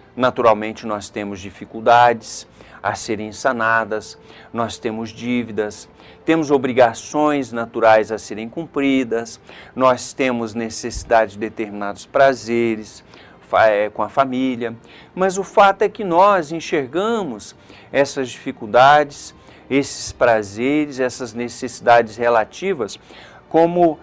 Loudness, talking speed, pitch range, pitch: -18 LUFS, 100 wpm, 110-135 Hz, 115 Hz